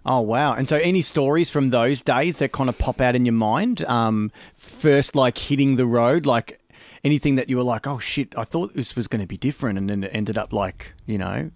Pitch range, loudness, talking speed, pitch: 110-145 Hz, -21 LUFS, 245 wpm, 125 Hz